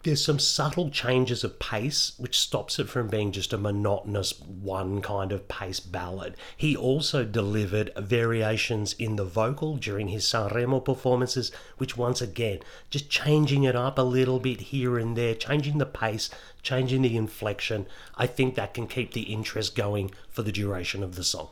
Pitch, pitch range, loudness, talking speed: 115 Hz, 105-130 Hz, -27 LUFS, 175 wpm